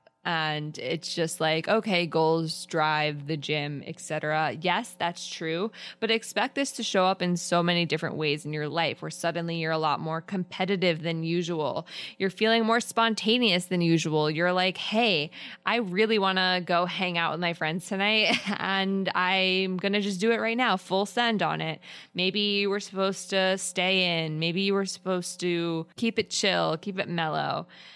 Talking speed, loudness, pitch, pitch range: 185 wpm, -26 LUFS, 180 Hz, 165-200 Hz